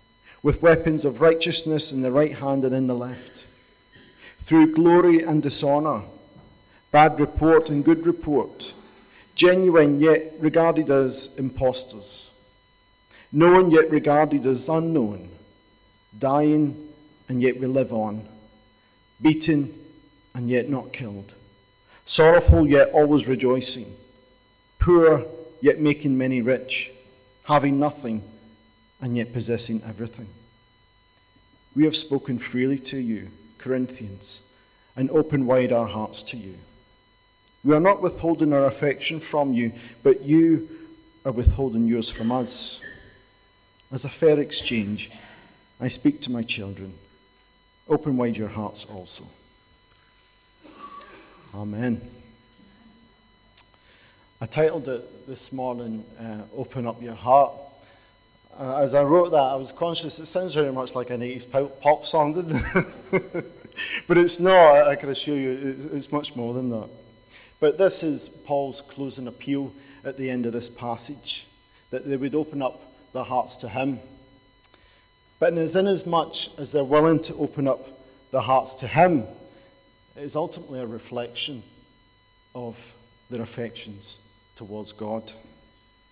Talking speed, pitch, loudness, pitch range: 130 wpm, 130 Hz, -22 LUFS, 110-150 Hz